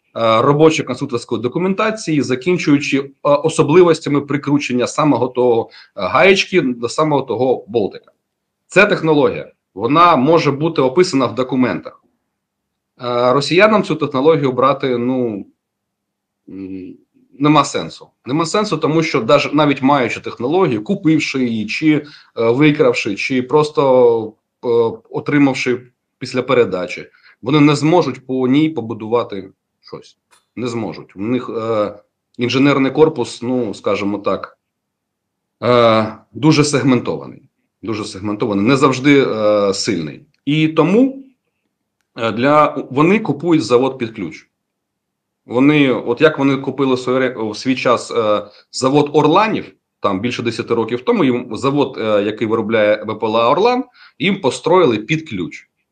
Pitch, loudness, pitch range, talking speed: 135 Hz, -15 LUFS, 120-155 Hz, 115 wpm